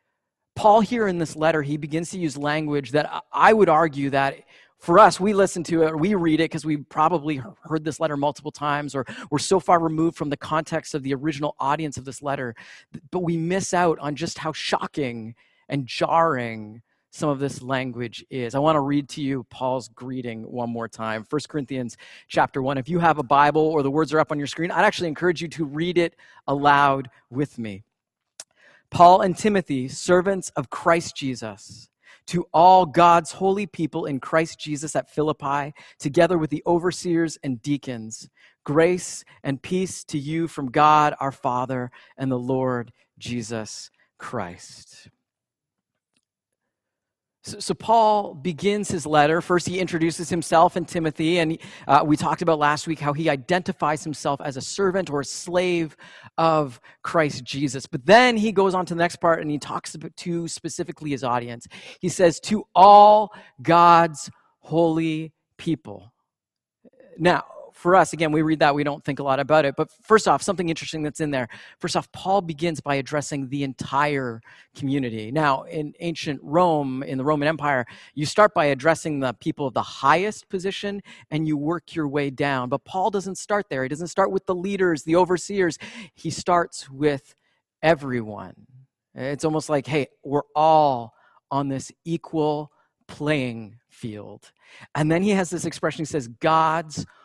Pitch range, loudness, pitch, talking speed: 140-170 Hz, -22 LUFS, 155 Hz, 175 wpm